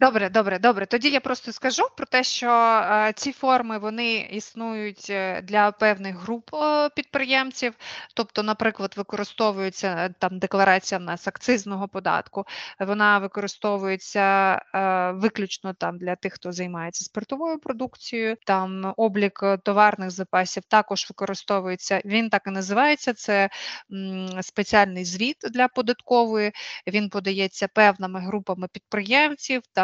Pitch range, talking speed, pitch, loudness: 195-235 Hz, 115 wpm, 210 Hz, -23 LUFS